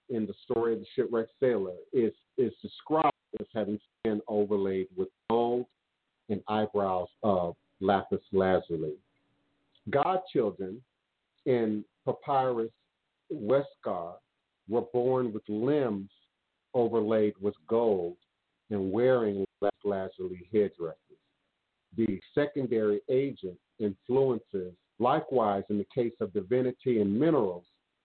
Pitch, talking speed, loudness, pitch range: 105 Hz, 105 wpm, -30 LUFS, 95-125 Hz